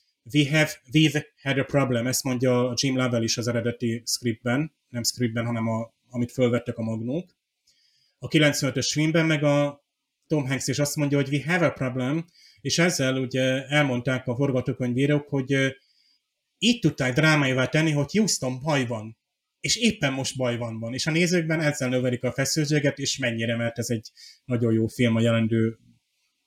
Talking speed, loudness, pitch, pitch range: 170 wpm, -24 LUFS, 130 Hz, 120-145 Hz